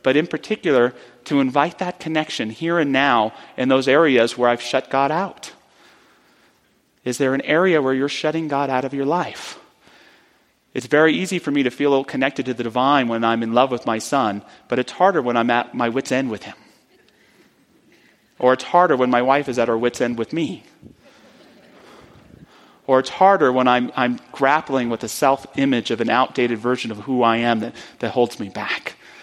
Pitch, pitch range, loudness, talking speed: 130 Hz, 120-145 Hz, -19 LUFS, 195 wpm